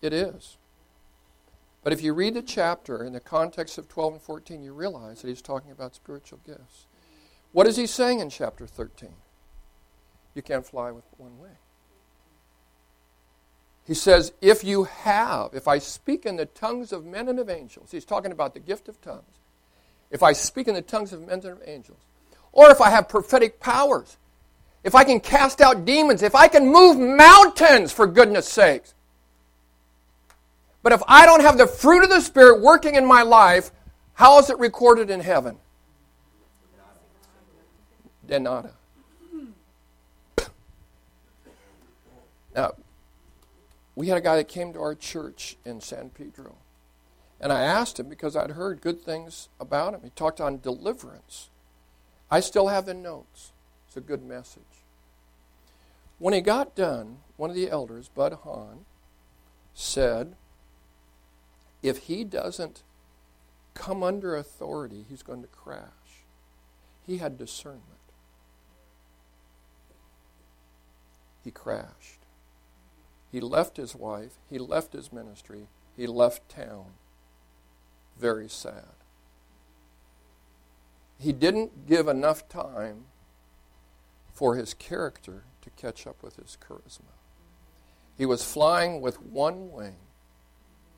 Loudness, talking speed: -17 LUFS, 135 wpm